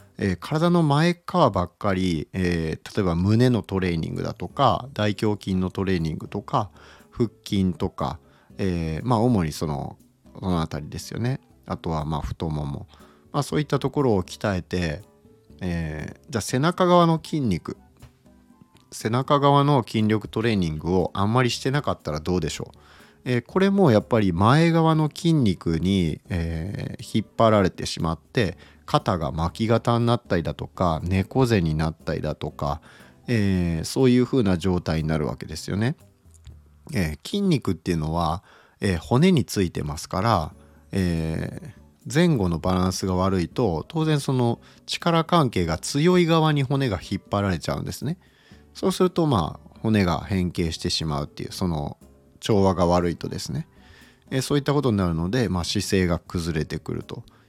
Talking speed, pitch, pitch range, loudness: 325 characters per minute, 95 Hz, 85-125 Hz, -24 LUFS